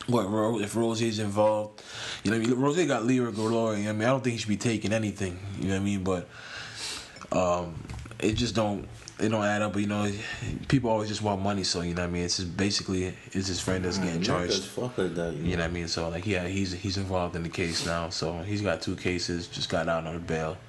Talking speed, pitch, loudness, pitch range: 250 wpm, 100 Hz, -29 LUFS, 90-110 Hz